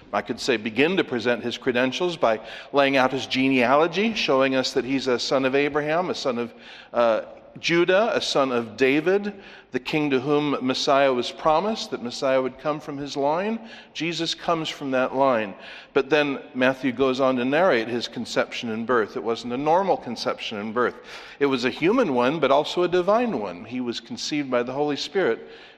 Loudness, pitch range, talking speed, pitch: -23 LUFS, 130-160 Hz, 195 wpm, 140 Hz